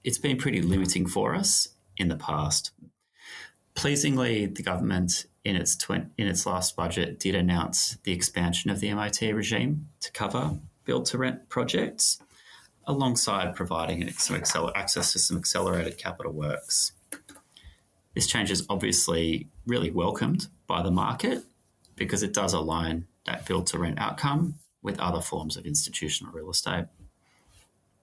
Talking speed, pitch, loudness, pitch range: 145 wpm, 95 Hz, -27 LUFS, 85-115 Hz